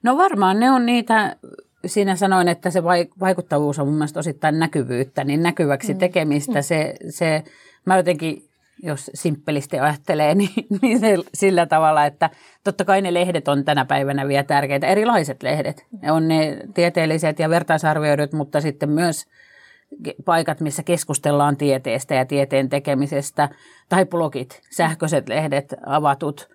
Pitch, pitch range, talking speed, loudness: 160 Hz, 145-185 Hz, 140 wpm, -20 LUFS